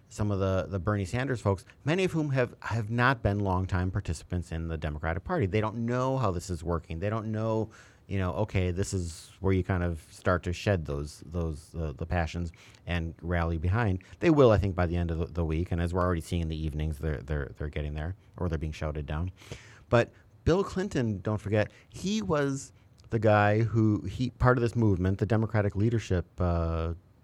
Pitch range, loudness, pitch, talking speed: 85-110 Hz, -30 LUFS, 95 Hz, 215 wpm